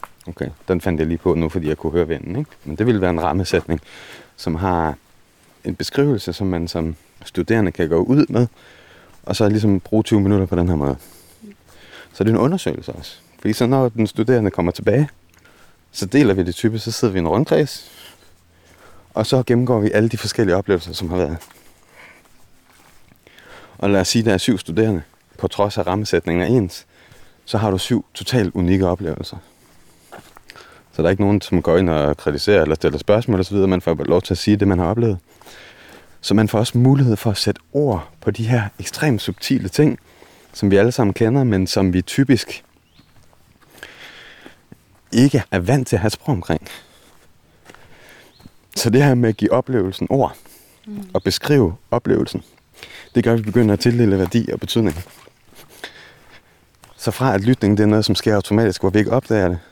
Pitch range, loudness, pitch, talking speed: 90-115 Hz, -18 LUFS, 100 Hz, 190 wpm